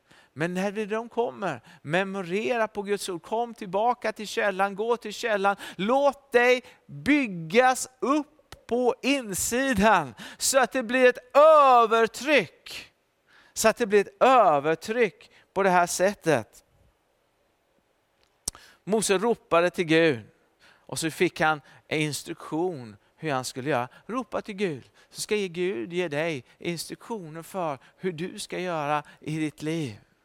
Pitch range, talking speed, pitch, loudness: 160-230 Hz, 135 wpm, 195 Hz, -25 LUFS